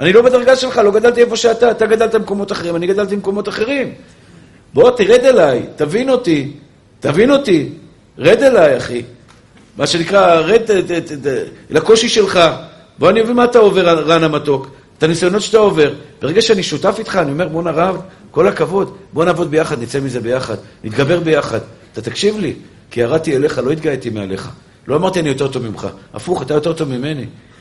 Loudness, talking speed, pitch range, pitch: -14 LUFS, 180 wpm, 140-215 Hz, 170 Hz